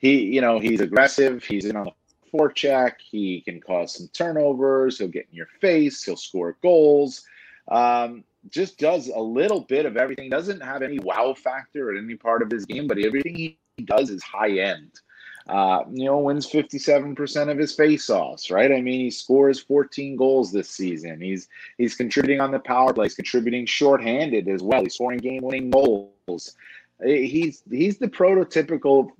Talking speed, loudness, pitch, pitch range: 180 wpm, -22 LUFS, 135 Hz, 120-145 Hz